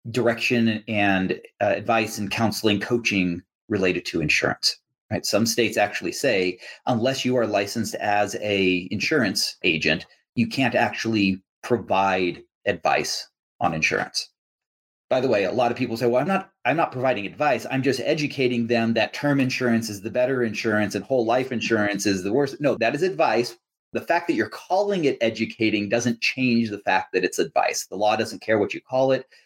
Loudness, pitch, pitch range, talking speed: -23 LUFS, 115 Hz, 105-125 Hz, 180 wpm